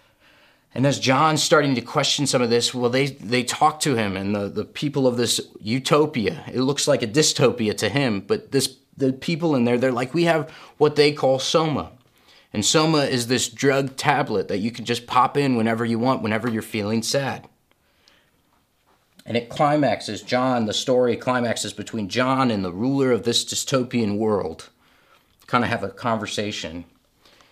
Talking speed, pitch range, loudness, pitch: 180 wpm, 115-140 Hz, -21 LUFS, 125 Hz